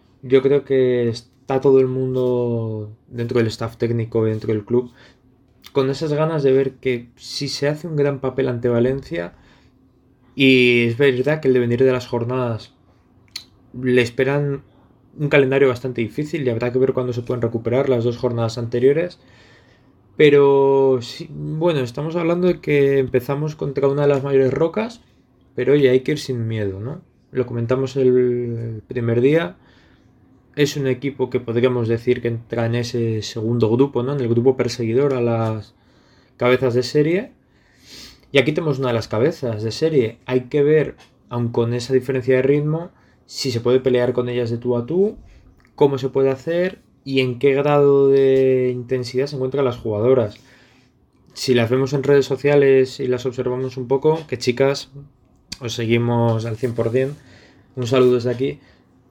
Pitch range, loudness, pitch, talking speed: 120-135 Hz, -19 LUFS, 130 Hz, 170 wpm